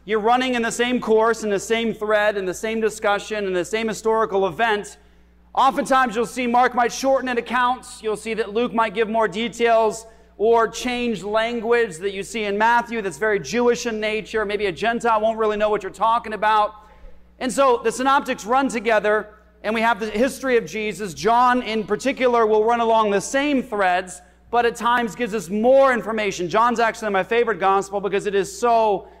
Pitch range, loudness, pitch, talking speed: 210-235 Hz, -20 LUFS, 225 Hz, 195 wpm